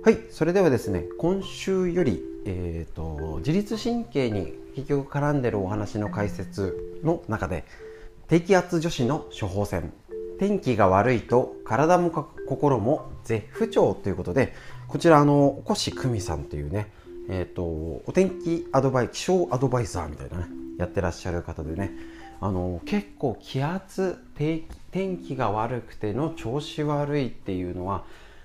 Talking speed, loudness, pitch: 285 characters per minute, -26 LUFS, 120 Hz